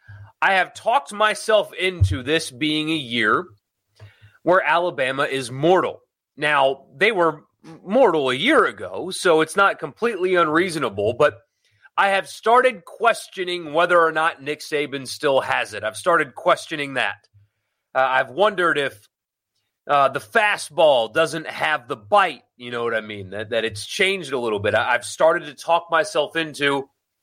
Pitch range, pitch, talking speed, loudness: 120-180 Hz, 155 Hz, 160 wpm, -20 LUFS